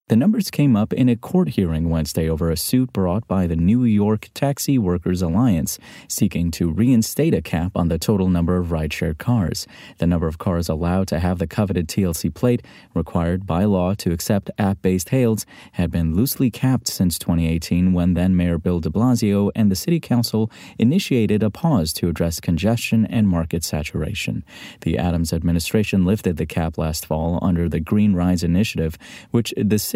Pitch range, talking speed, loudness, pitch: 85-110 Hz, 185 wpm, -20 LUFS, 90 Hz